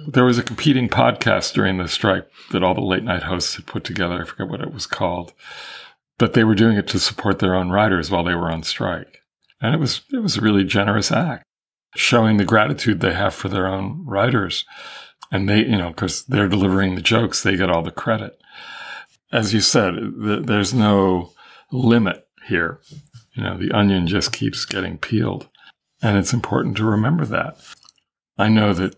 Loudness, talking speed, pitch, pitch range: -19 LUFS, 195 wpm, 105 Hz, 95-115 Hz